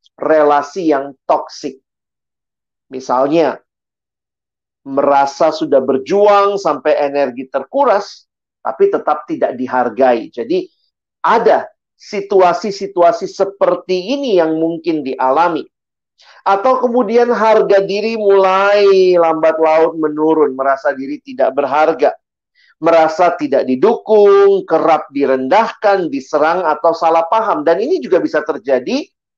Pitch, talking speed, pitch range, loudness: 170 Hz, 100 wpm, 150-205 Hz, -13 LUFS